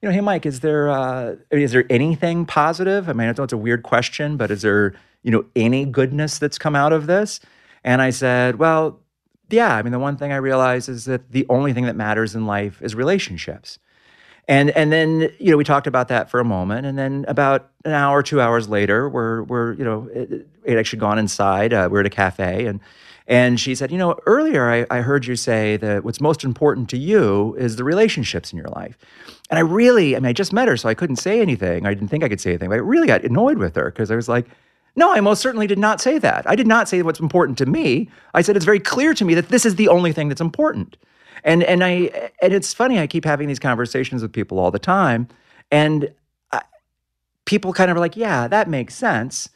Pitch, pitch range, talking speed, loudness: 140 Hz, 115-170 Hz, 245 wpm, -18 LUFS